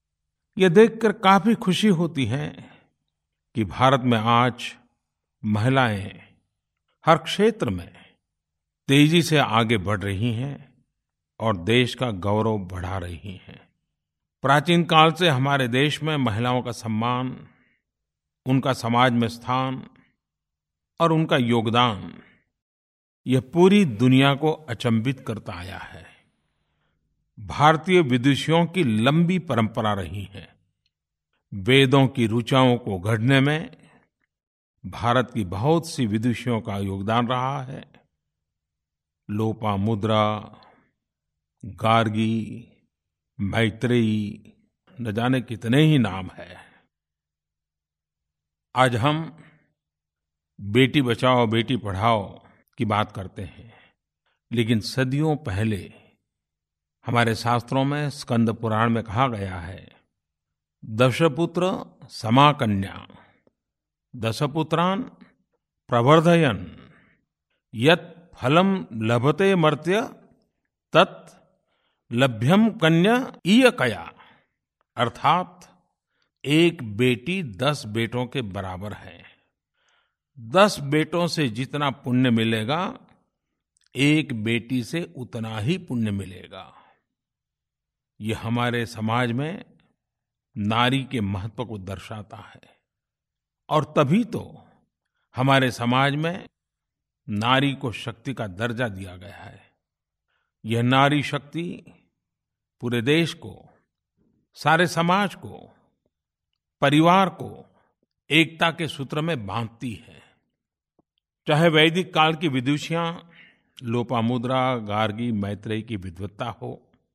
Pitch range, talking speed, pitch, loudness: 105-145 Hz, 95 wpm, 120 Hz, -22 LUFS